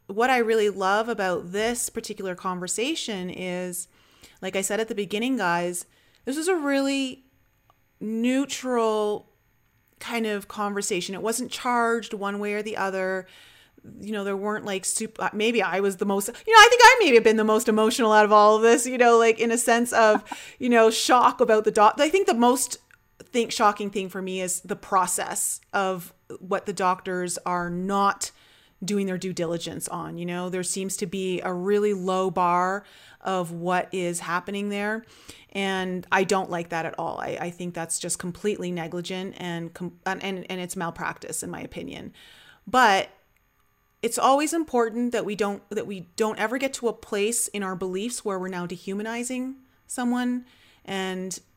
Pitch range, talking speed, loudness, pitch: 185-230 Hz, 180 wpm, -24 LUFS, 205 Hz